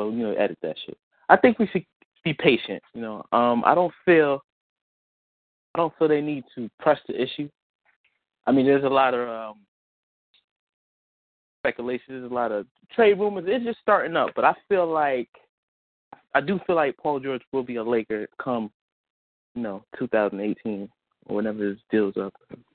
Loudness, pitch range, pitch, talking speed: -24 LUFS, 105-150 Hz, 125 Hz, 175 wpm